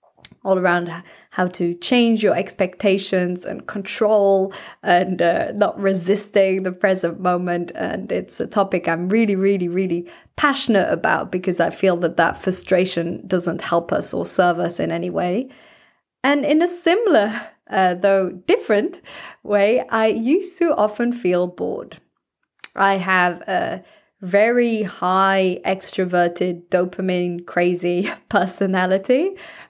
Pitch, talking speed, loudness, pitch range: 190 Hz, 130 wpm, -19 LUFS, 180-210 Hz